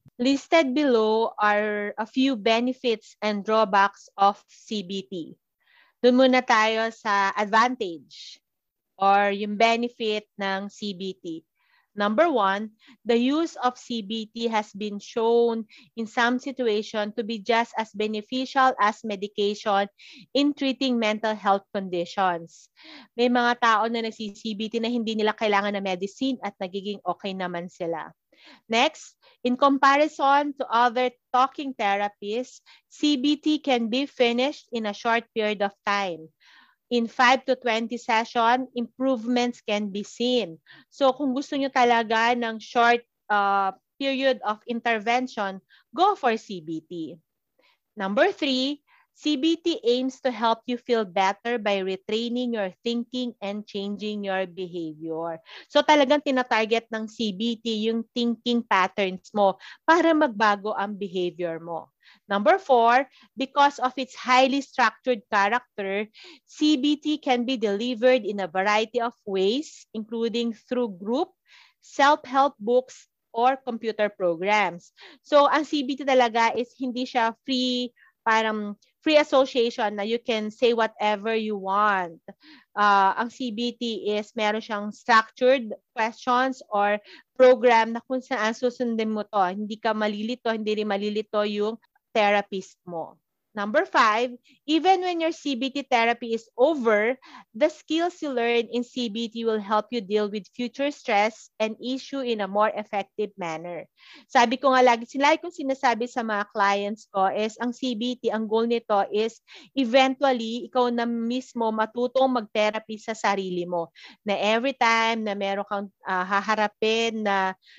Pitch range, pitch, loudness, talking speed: 205-255 Hz, 230 Hz, -24 LUFS, 135 wpm